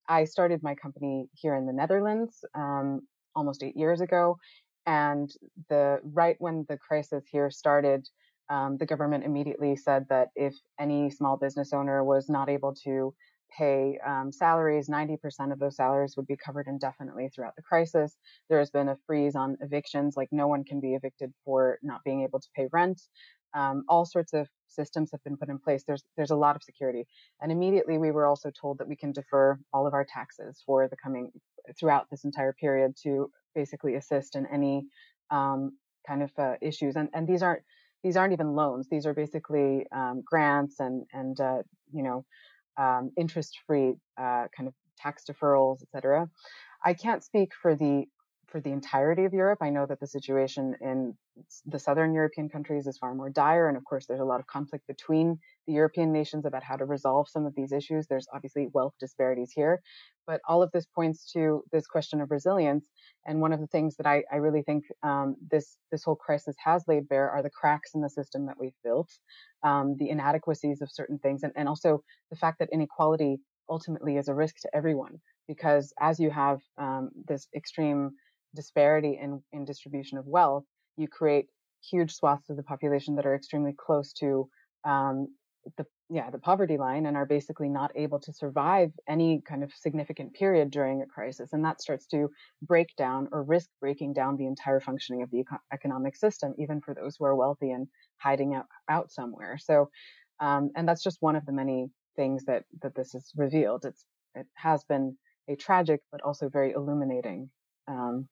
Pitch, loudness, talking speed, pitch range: 145 Hz, -29 LUFS, 195 wpm, 135-155 Hz